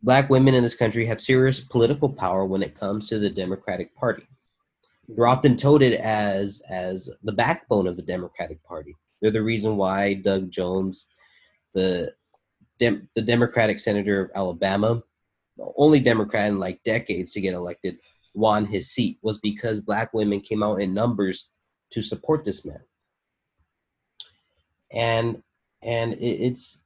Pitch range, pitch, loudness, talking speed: 95-115 Hz, 105 Hz, -23 LUFS, 150 wpm